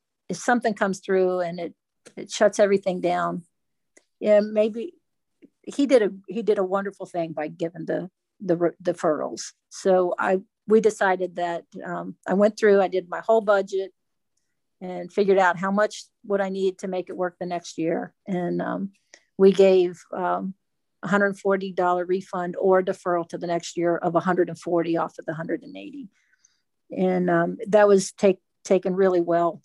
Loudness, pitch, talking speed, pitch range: -23 LUFS, 185 Hz, 170 wpm, 175-200 Hz